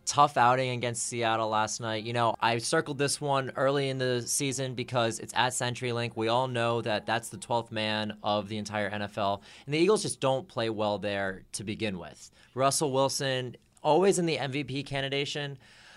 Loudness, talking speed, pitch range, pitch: -29 LUFS, 190 wpm, 110-135 Hz, 120 Hz